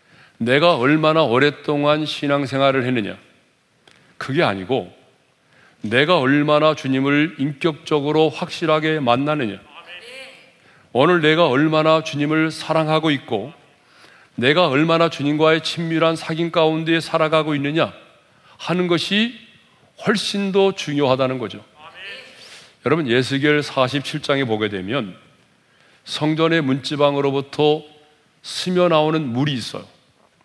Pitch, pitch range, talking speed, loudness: 155 Hz, 145-165 Hz, 255 characters per minute, -18 LUFS